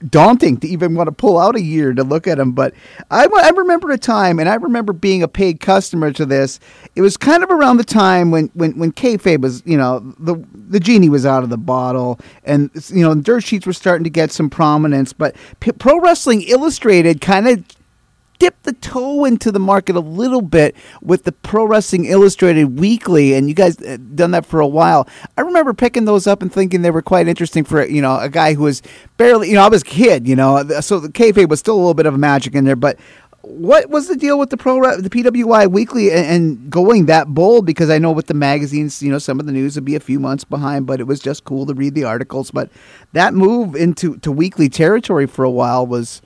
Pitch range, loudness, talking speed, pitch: 145-210 Hz, -13 LUFS, 240 wpm, 170 Hz